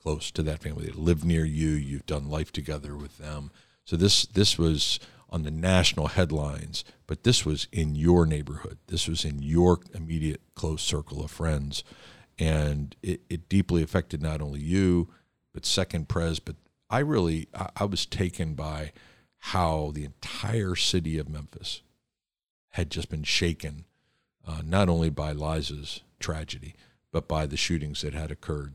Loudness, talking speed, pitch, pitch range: -28 LUFS, 165 wpm, 80 Hz, 75-90 Hz